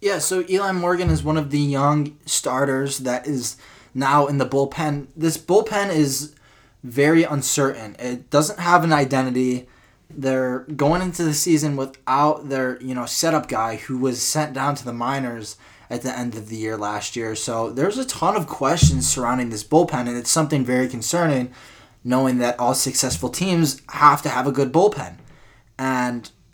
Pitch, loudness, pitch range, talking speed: 135 Hz, -21 LUFS, 125-150 Hz, 175 wpm